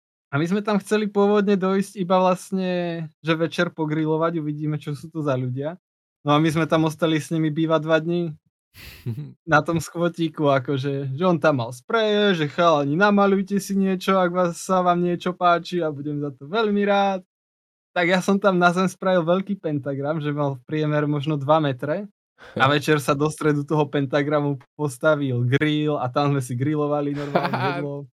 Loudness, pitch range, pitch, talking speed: -22 LUFS, 145-180 Hz, 160 Hz, 190 wpm